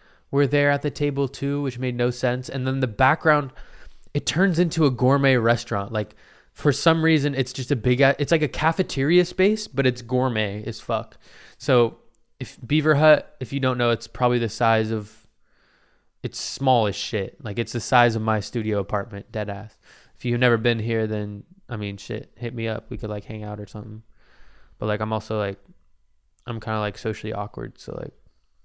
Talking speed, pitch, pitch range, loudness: 200 wpm, 120 Hz, 110-140 Hz, -23 LUFS